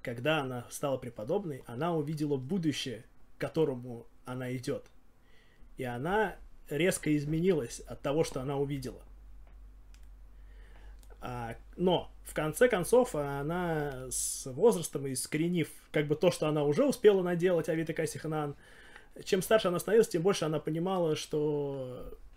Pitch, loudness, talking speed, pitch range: 155 Hz, -31 LUFS, 125 wpm, 135-175 Hz